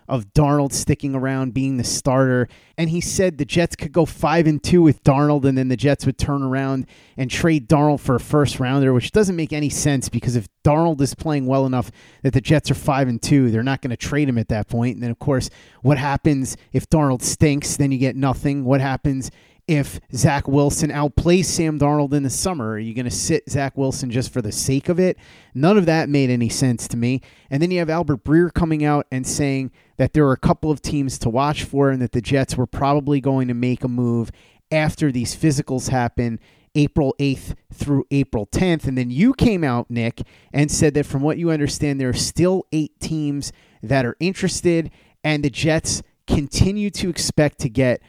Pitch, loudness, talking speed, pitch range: 140 Hz, -20 LUFS, 220 wpm, 130-155 Hz